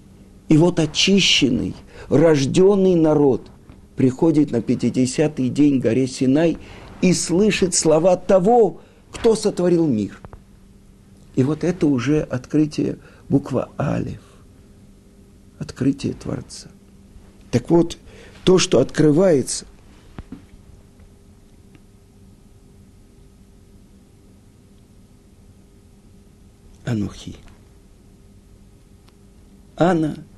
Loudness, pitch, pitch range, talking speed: -18 LUFS, 105 Hz, 100-155 Hz, 70 wpm